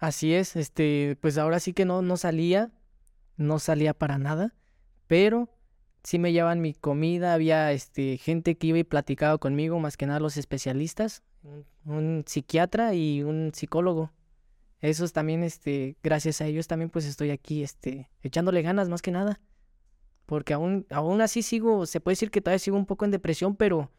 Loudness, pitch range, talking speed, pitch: -27 LUFS, 150-180 Hz, 175 wpm, 160 Hz